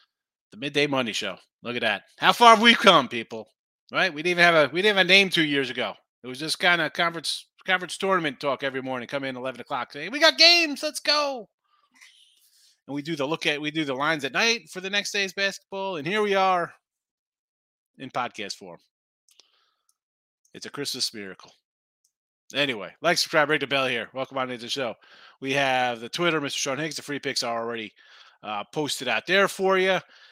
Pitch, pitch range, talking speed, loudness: 160 Hz, 135-195 Hz, 210 wpm, -23 LUFS